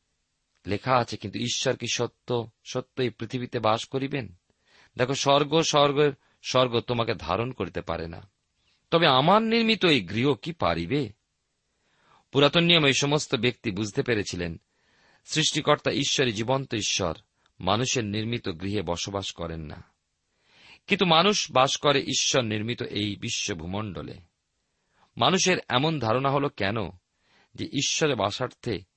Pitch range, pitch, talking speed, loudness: 100-140 Hz, 120 Hz, 120 wpm, -25 LUFS